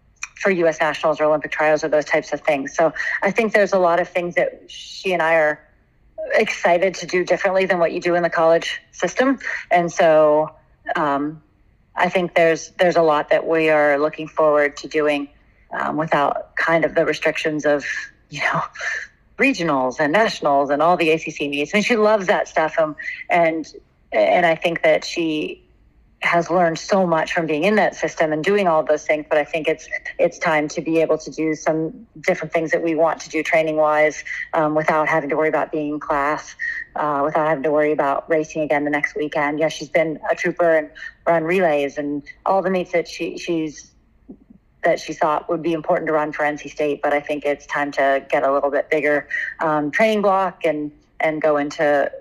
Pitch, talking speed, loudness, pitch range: 160 Hz, 210 wpm, -19 LUFS, 150-175 Hz